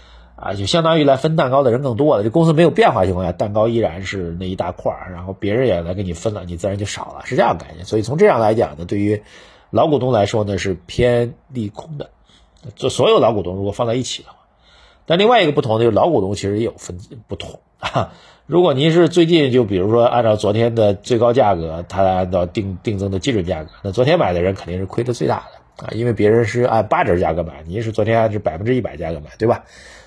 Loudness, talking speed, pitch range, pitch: -17 LUFS, 365 characters per minute, 95-125 Hz, 110 Hz